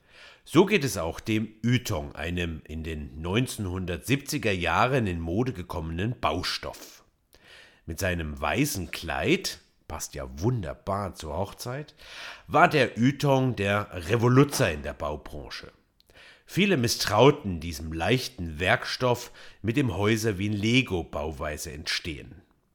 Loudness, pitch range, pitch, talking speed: -27 LUFS, 80-125 Hz, 100 Hz, 115 wpm